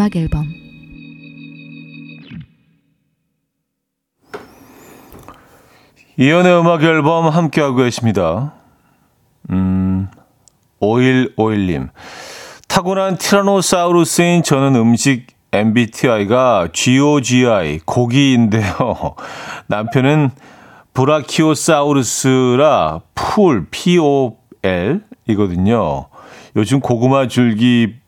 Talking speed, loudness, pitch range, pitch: 170 characters per minute, -14 LUFS, 115-155 Hz, 135 Hz